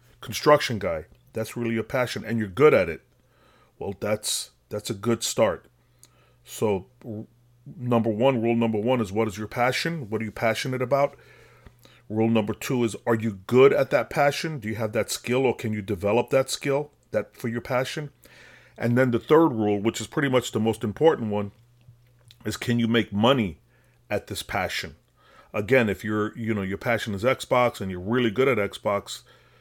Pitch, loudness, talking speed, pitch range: 115 Hz, -25 LUFS, 195 wpm, 110-125 Hz